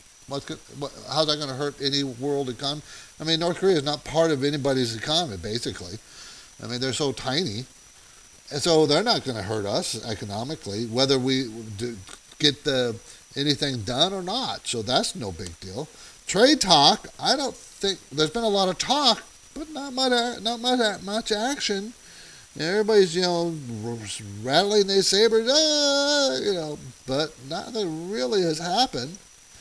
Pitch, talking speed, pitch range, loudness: 145 Hz, 160 wpm, 125-195 Hz, -23 LUFS